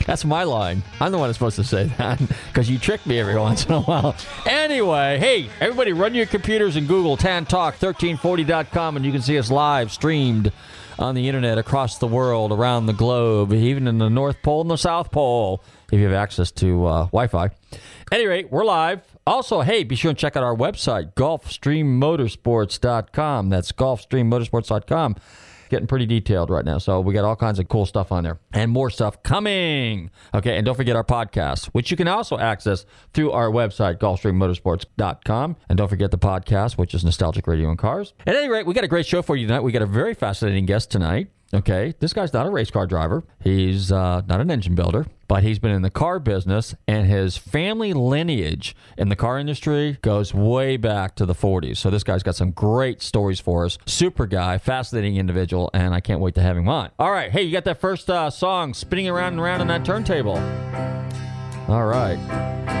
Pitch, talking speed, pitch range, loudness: 115 Hz, 205 wpm, 100-145 Hz, -21 LUFS